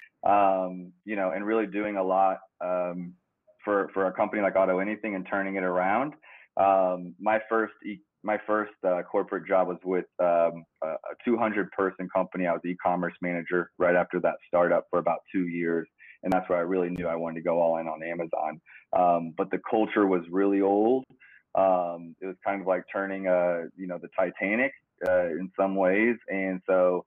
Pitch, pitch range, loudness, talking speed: 95 Hz, 90-100 Hz, -27 LUFS, 195 wpm